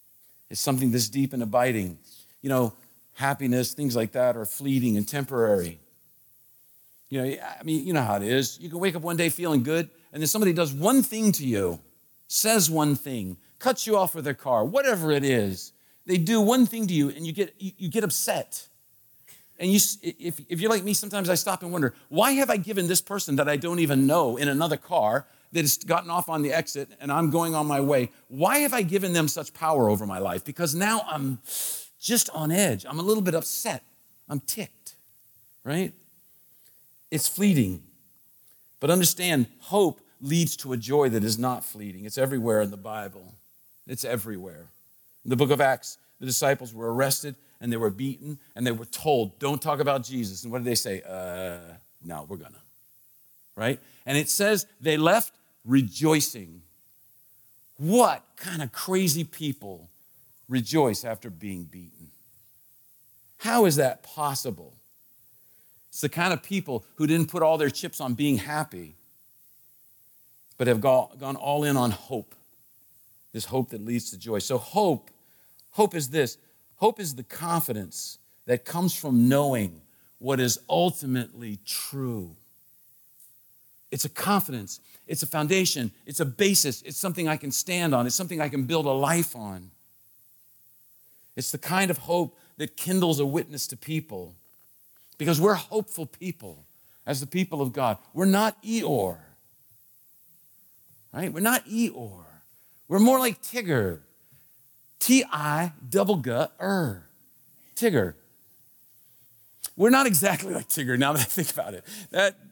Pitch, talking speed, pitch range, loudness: 140 Hz, 165 wpm, 120-170 Hz, -25 LUFS